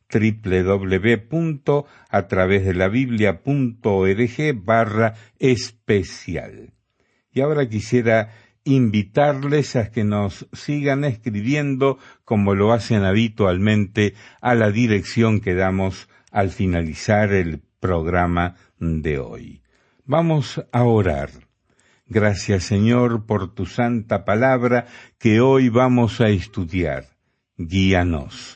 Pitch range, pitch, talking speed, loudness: 95-125 Hz, 110 Hz, 90 wpm, -20 LUFS